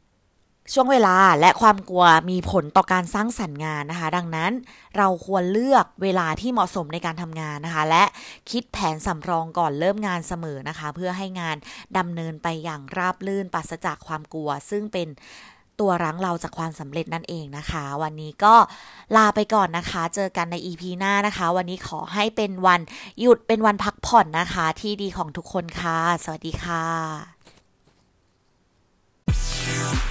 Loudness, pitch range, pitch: -22 LUFS, 160-200 Hz, 180 Hz